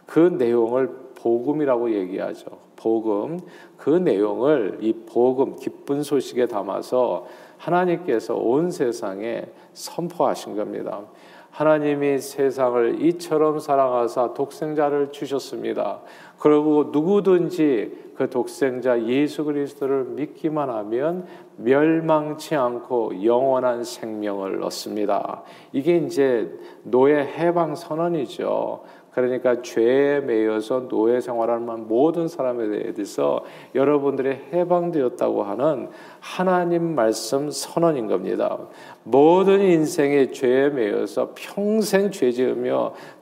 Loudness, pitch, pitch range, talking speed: -22 LUFS, 145 Hz, 125-165 Hz, 255 characters per minute